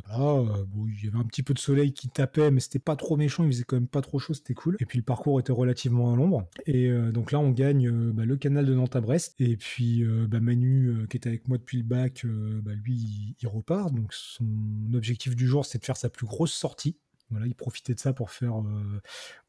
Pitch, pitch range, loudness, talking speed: 125 Hz, 115-140 Hz, -27 LUFS, 270 wpm